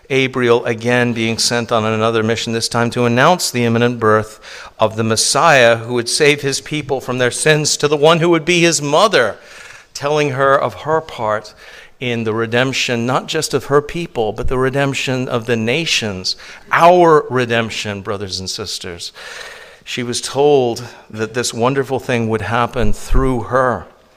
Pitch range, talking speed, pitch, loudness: 115-140 Hz, 170 wpm, 125 Hz, -15 LUFS